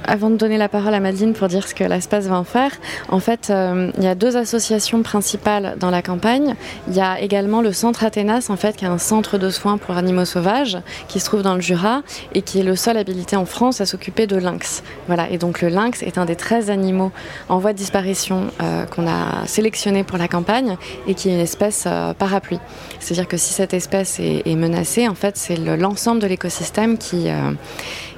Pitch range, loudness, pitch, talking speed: 180-215 Hz, -19 LUFS, 195 Hz, 230 wpm